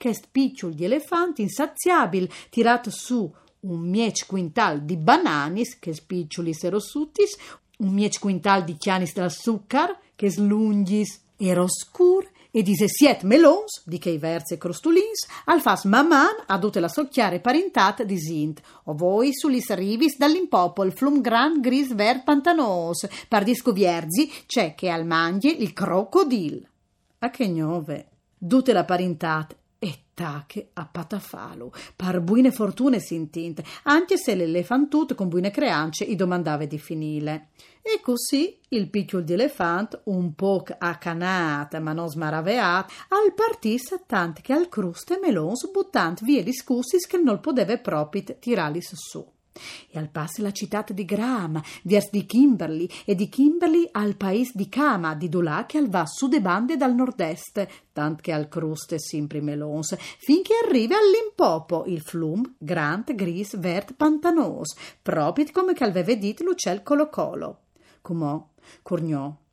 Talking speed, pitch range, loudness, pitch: 140 wpm, 175-270 Hz, -23 LUFS, 205 Hz